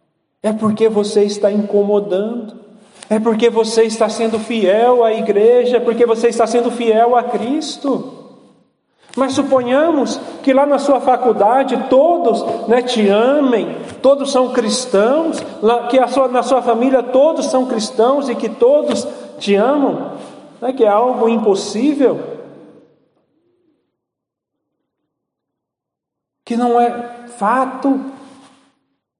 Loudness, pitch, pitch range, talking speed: -15 LUFS, 240 Hz, 225-270 Hz, 120 wpm